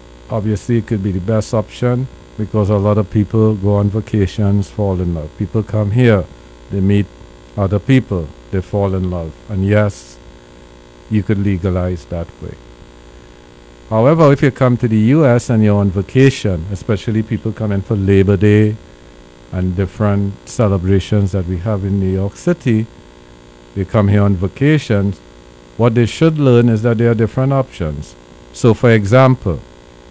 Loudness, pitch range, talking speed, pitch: -15 LUFS, 80-110 Hz, 165 wpm, 100 Hz